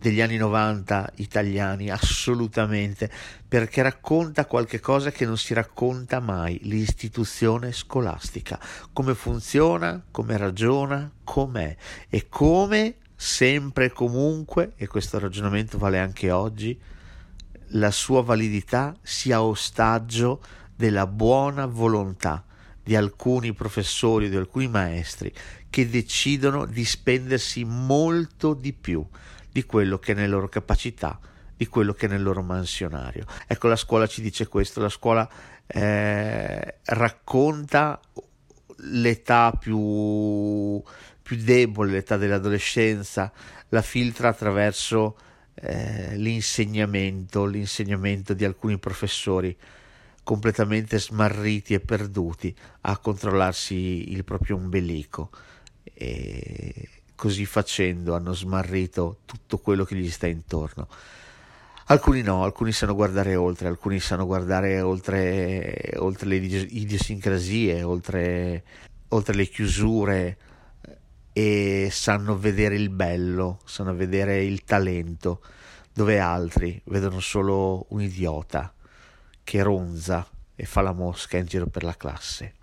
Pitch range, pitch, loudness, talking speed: 95-115 Hz, 105 Hz, -25 LUFS, 115 wpm